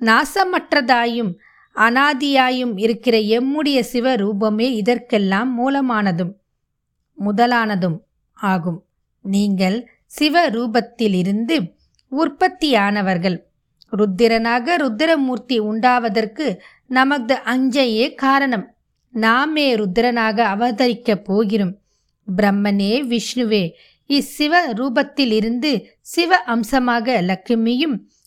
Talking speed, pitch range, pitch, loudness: 60 wpm, 215-265 Hz, 235 Hz, -18 LUFS